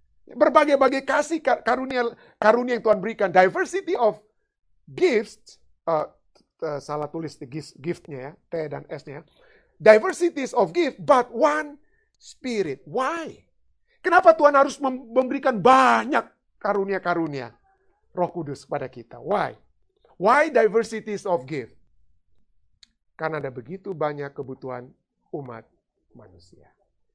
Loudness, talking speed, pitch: -22 LUFS, 110 wpm, 225 Hz